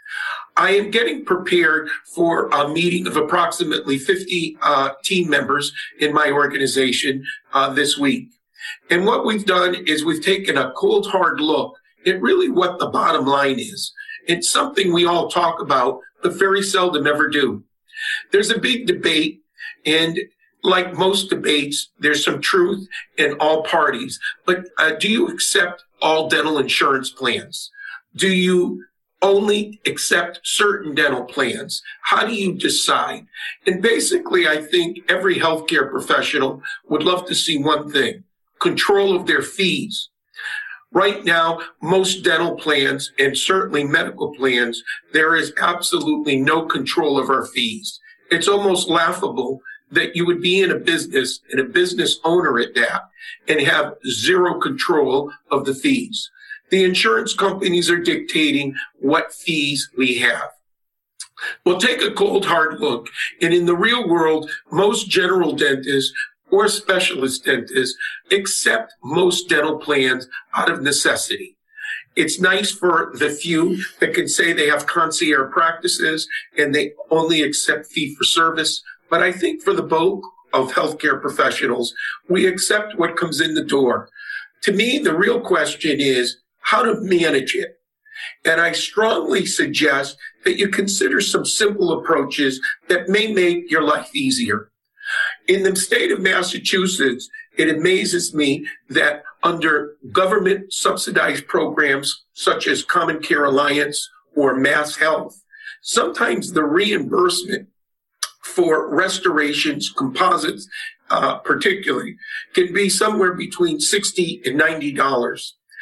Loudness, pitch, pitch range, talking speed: -18 LUFS, 185 Hz, 155-255 Hz, 140 wpm